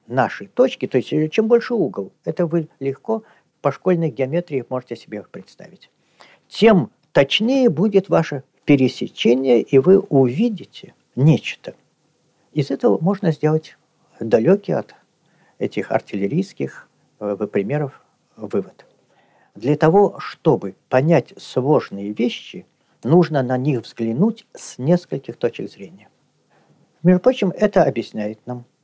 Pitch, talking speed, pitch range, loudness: 155 Hz, 110 wpm, 130-190 Hz, -19 LUFS